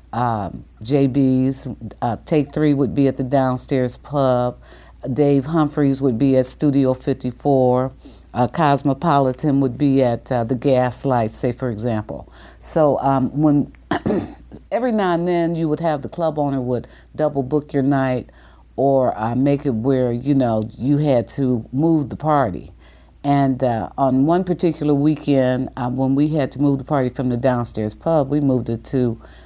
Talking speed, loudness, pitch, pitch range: 170 wpm, -19 LUFS, 135 Hz, 125-145 Hz